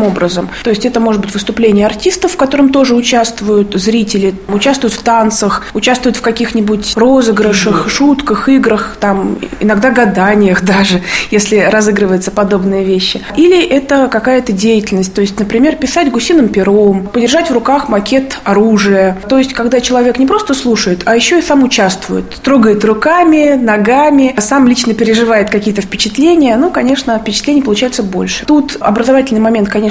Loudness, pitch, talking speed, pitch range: -10 LUFS, 225 Hz, 150 wpm, 205-265 Hz